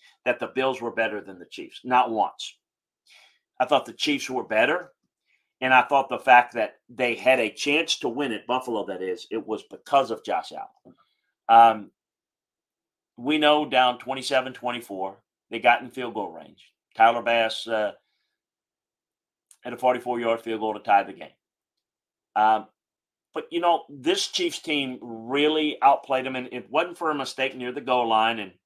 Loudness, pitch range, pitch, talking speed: -24 LUFS, 115-145 Hz, 125 Hz, 170 wpm